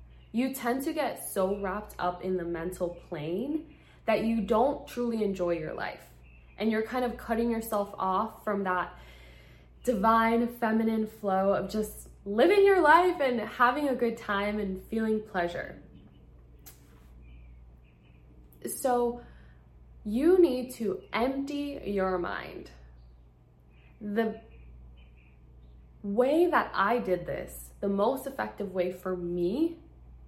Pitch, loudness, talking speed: 200 Hz, -29 LUFS, 125 wpm